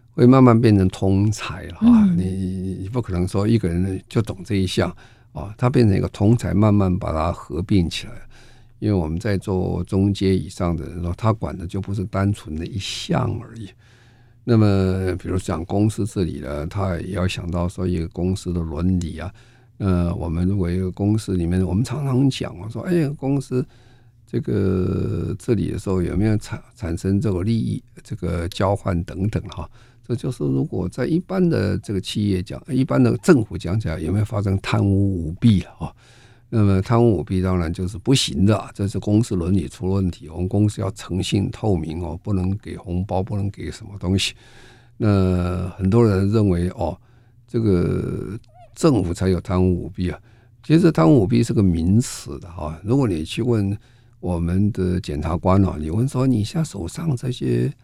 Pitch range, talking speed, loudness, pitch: 90-115 Hz, 275 characters per minute, -21 LUFS, 100 Hz